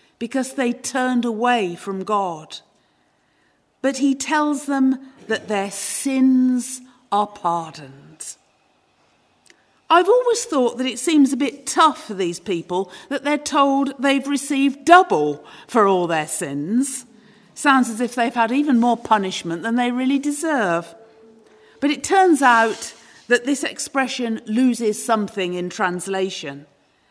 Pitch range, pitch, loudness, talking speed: 200-275 Hz, 245 Hz, -19 LUFS, 135 wpm